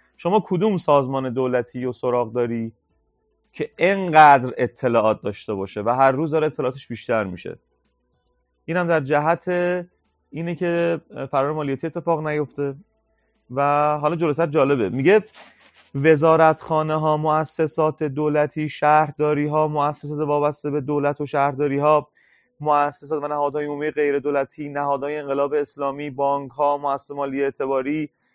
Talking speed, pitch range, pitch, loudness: 130 wpm, 140-155 Hz, 145 Hz, -21 LUFS